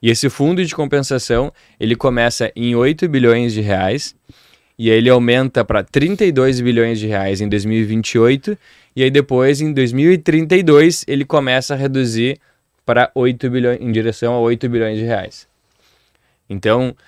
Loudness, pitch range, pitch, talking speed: -15 LUFS, 115-140 Hz, 125 Hz, 150 wpm